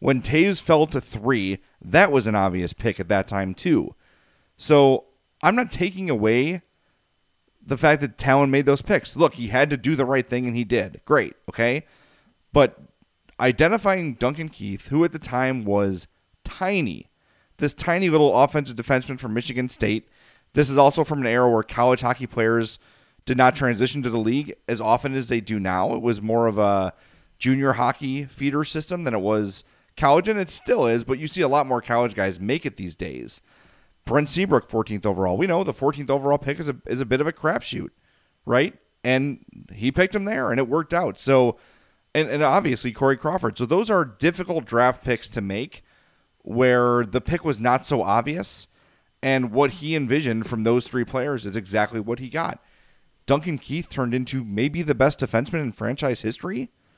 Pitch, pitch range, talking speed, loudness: 130 Hz, 115-145 Hz, 190 wpm, -22 LUFS